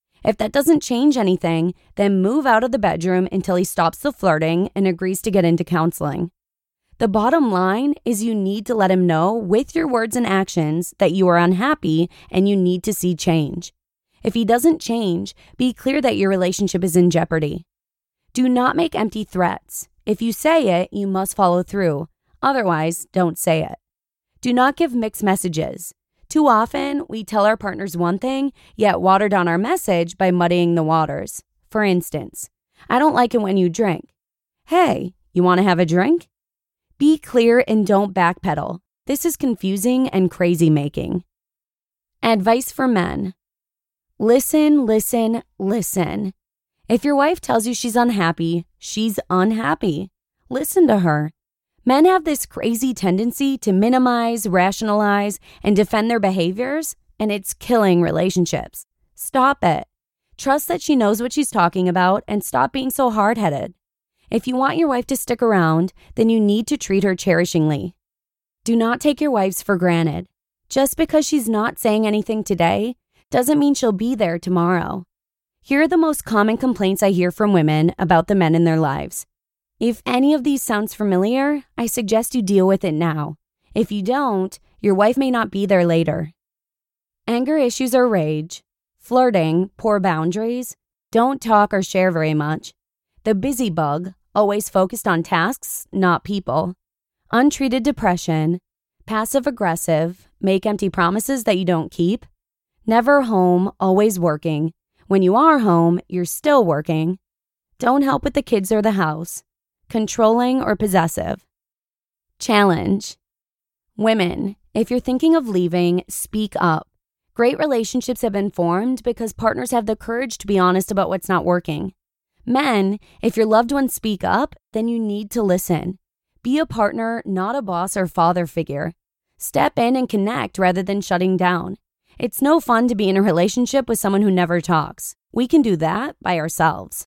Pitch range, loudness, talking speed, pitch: 180-240 Hz, -19 LUFS, 165 wpm, 205 Hz